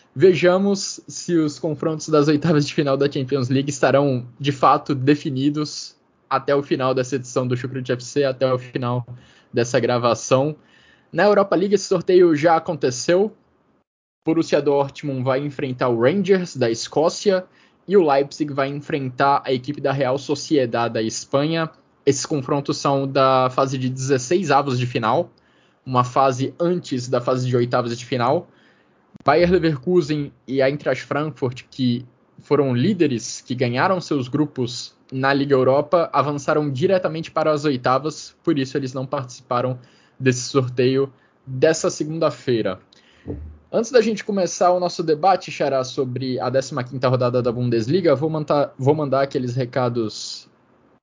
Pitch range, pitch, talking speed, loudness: 130-155 Hz, 140 Hz, 145 wpm, -20 LUFS